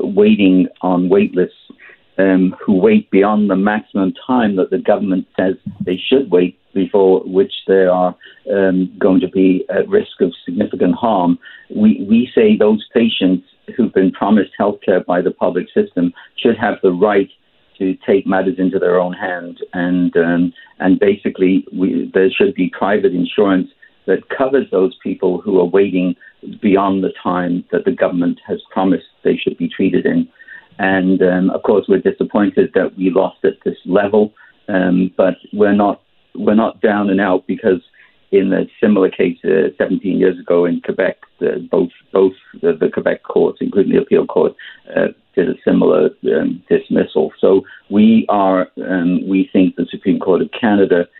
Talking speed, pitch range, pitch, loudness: 170 wpm, 90-105 Hz, 95 Hz, -15 LUFS